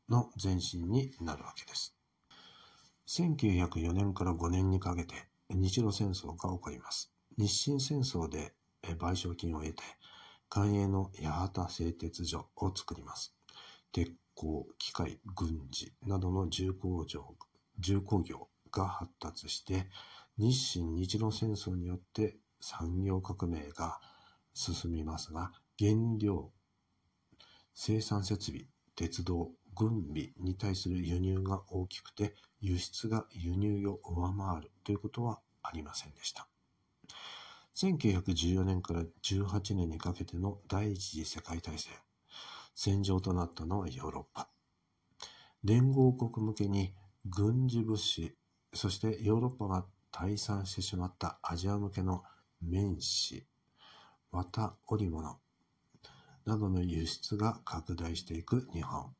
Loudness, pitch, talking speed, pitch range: -36 LUFS, 95 Hz, 220 characters per minute, 85-105 Hz